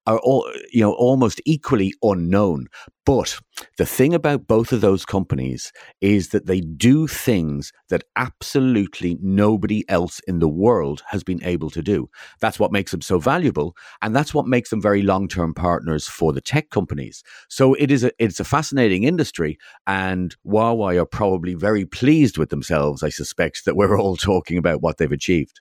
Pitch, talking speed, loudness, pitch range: 100 Hz, 180 wpm, -20 LUFS, 85-115 Hz